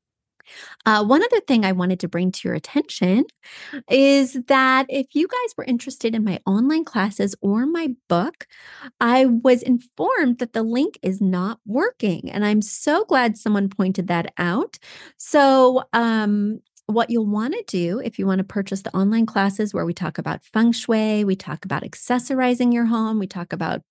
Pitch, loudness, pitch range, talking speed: 225 Hz, -20 LUFS, 195-260 Hz, 180 wpm